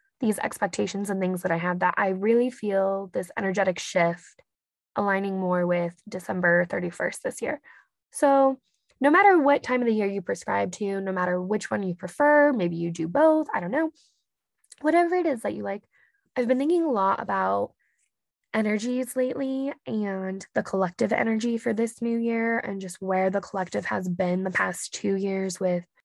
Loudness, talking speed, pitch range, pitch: -25 LUFS, 180 wpm, 185-250 Hz, 200 Hz